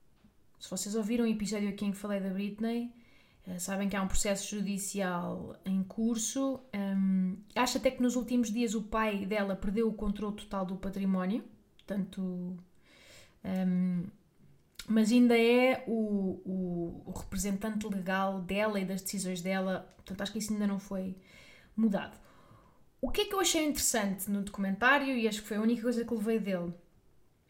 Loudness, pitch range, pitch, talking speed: -32 LUFS, 190-225 Hz, 200 Hz, 170 wpm